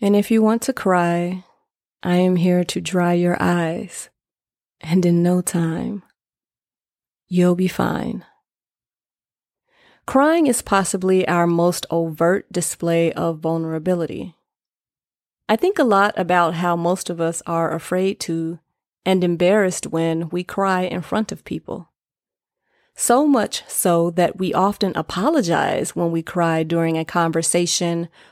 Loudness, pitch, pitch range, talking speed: -19 LUFS, 180 Hz, 170-195 Hz, 135 wpm